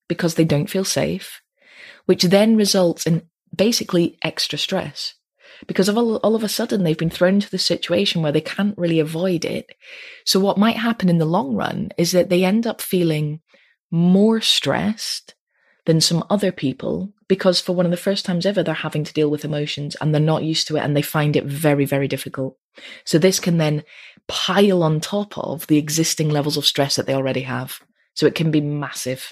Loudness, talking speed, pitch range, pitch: -19 LUFS, 205 wpm, 150-195 Hz, 170 Hz